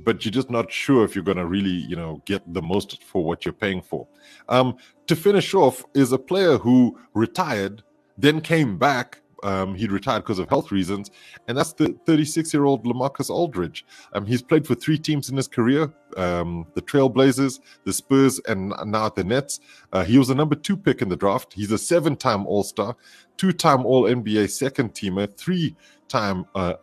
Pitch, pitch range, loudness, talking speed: 125 Hz, 100-145 Hz, -22 LUFS, 185 wpm